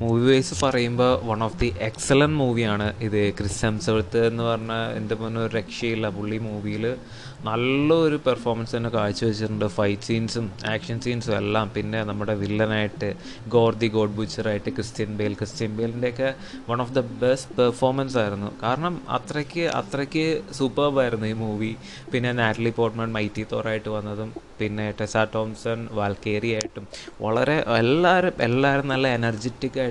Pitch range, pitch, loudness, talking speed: 110-125 Hz, 115 Hz, -24 LUFS, 135 wpm